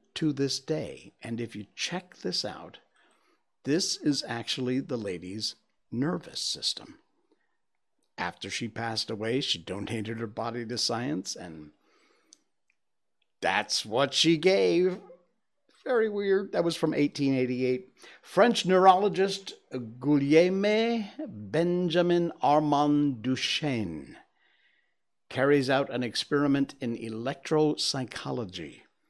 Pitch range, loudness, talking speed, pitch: 115-175 Hz, -28 LUFS, 100 wpm, 140 Hz